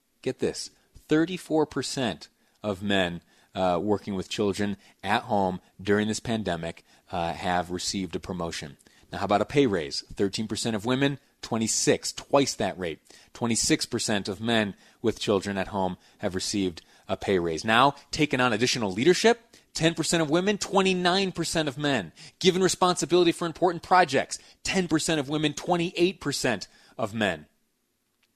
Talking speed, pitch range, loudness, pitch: 140 wpm, 100-160 Hz, -26 LUFS, 120 Hz